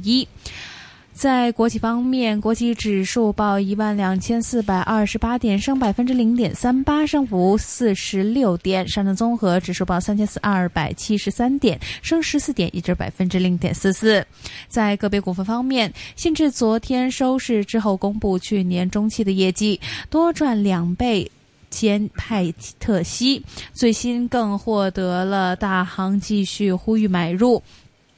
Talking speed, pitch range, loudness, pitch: 235 characters per minute, 190-235 Hz, -20 LUFS, 210 Hz